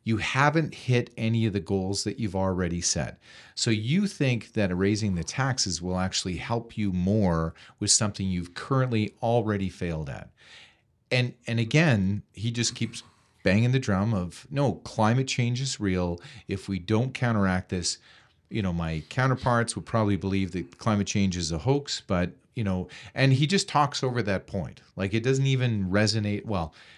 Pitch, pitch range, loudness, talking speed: 105 Hz, 95-120 Hz, -27 LUFS, 175 wpm